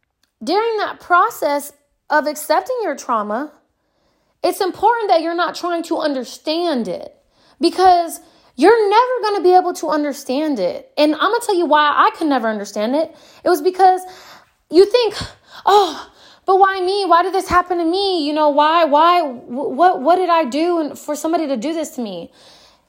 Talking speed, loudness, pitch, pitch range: 180 wpm, -16 LUFS, 335 Hz, 295-370 Hz